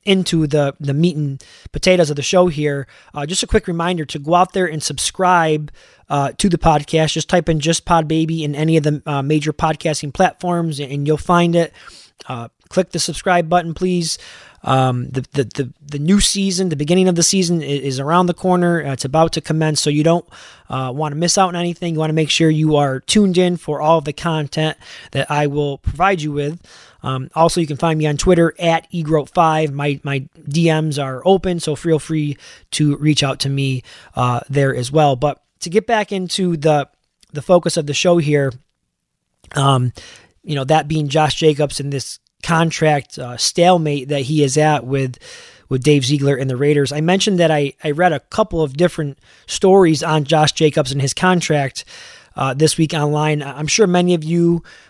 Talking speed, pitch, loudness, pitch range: 205 wpm, 155 Hz, -17 LUFS, 145-170 Hz